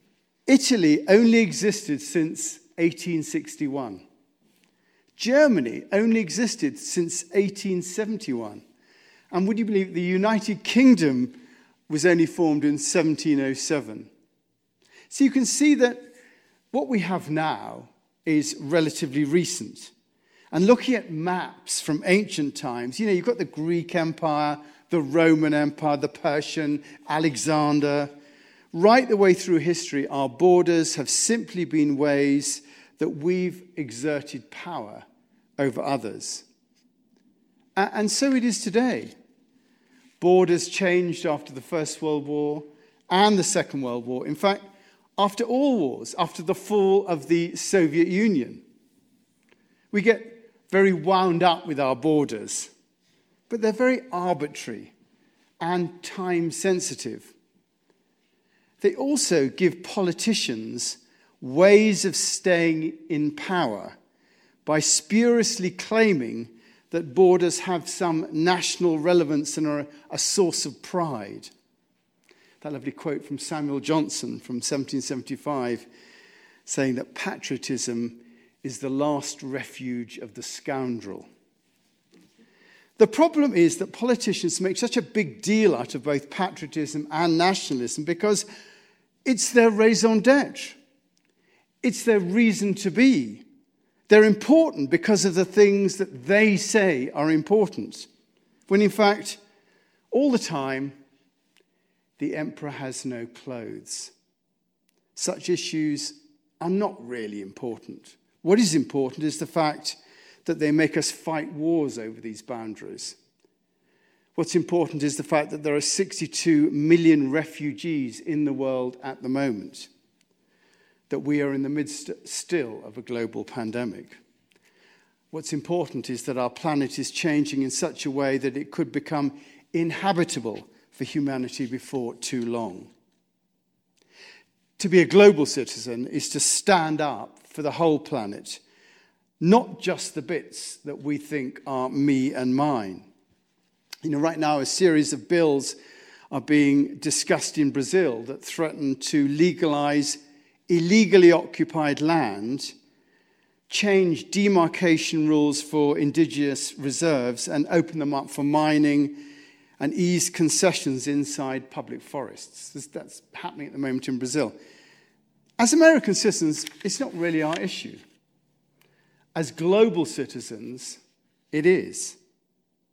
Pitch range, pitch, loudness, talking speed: 145-200 Hz, 165 Hz, -23 LUFS, 125 wpm